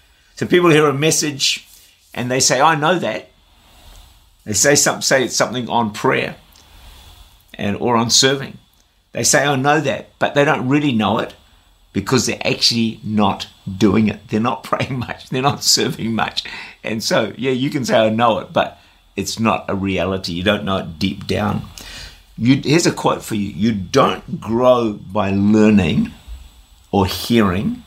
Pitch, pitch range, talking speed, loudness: 105 Hz, 90-130 Hz, 175 wpm, -17 LUFS